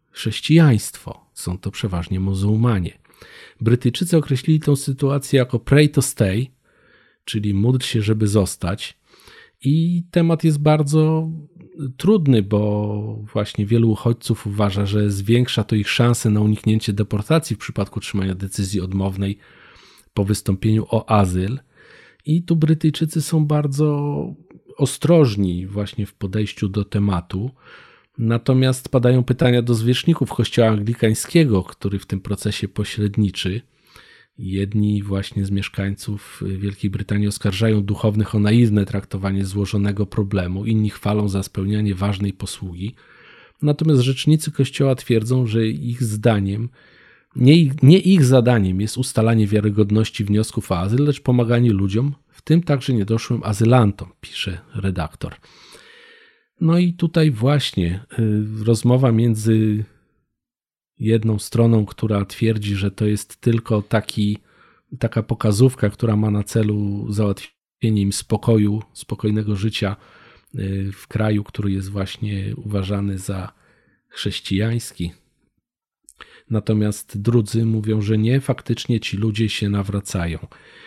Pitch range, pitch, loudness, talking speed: 100-125 Hz, 110 Hz, -19 LUFS, 115 wpm